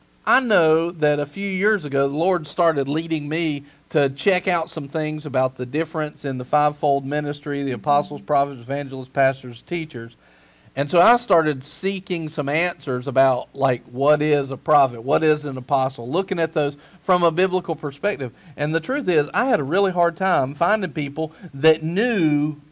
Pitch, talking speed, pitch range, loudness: 150 Hz, 180 wpm, 140-170 Hz, -21 LUFS